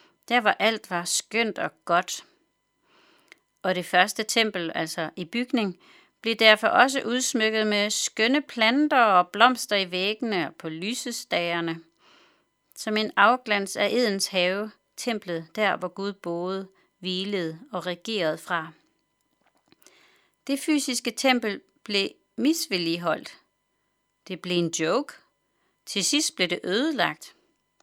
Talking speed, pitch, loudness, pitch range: 125 wpm, 210 Hz, -24 LUFS, 180-245 Hz